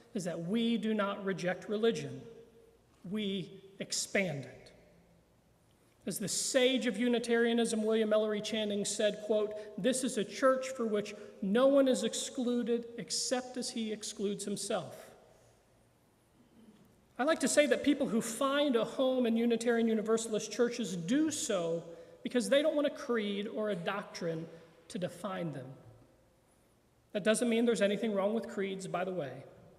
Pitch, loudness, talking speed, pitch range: 220 Hz, -33 LUFS, 150 wpm, 200-240 Hz